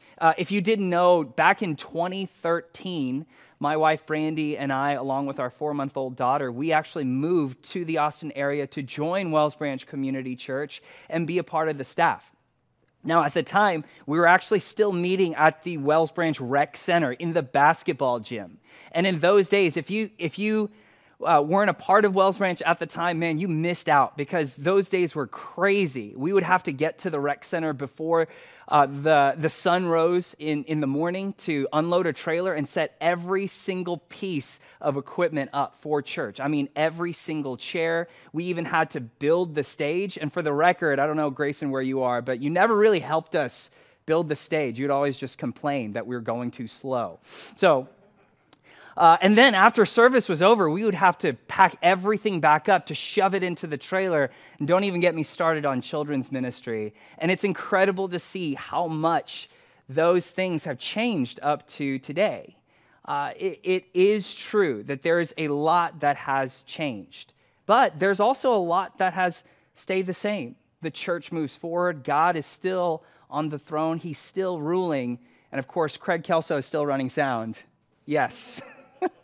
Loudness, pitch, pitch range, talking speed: -24 LUFS, 160 Hz, 145-180 Hz, 195 wpm